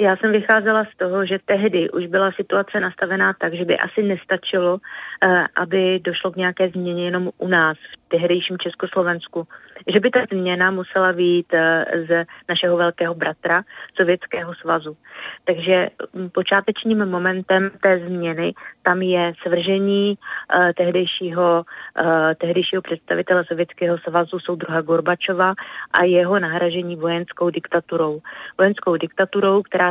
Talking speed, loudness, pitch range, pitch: 125 wpm, -19 LUFS, 170-190 Hz, 180 Hz